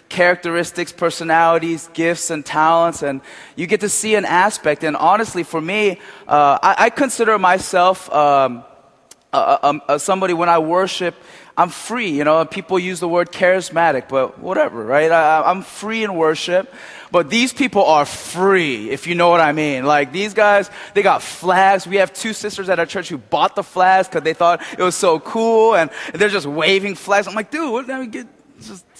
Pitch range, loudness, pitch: 165-200 Hz, -16 LUFS, 180 Hz